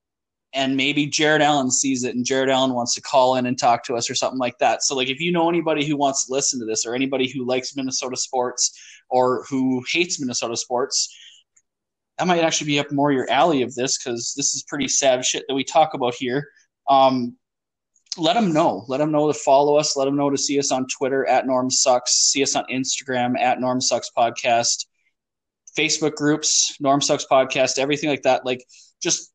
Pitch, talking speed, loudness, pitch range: 135 Hz, 215 wpm, -20 LUFS, 125-145 Hz